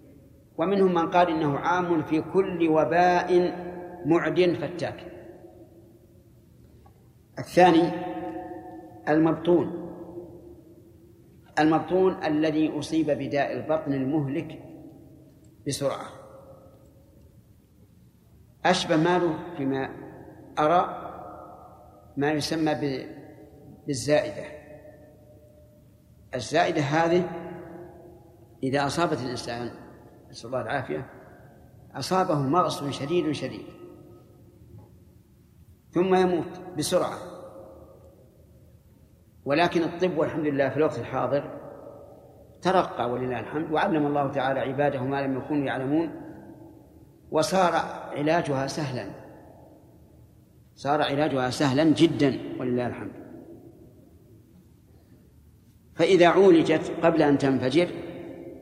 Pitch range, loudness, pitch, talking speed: 135-170 Hz, -25 LUFS, 150 Hz, 75 wpm